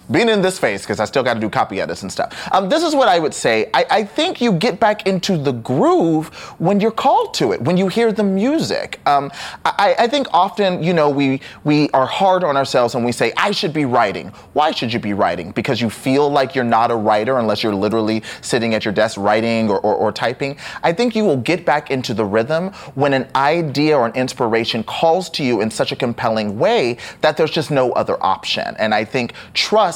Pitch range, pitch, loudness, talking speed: 115-190 Hz, 140 Hz, -17 LUFS, 235 wpm